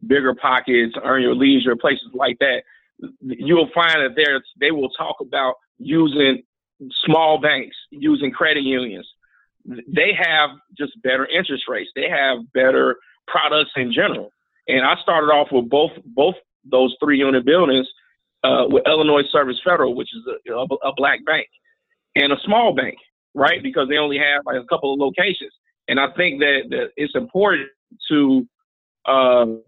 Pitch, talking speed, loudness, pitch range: 150 Hz, 160 wpm, -18 LUFS, 130-195 Hz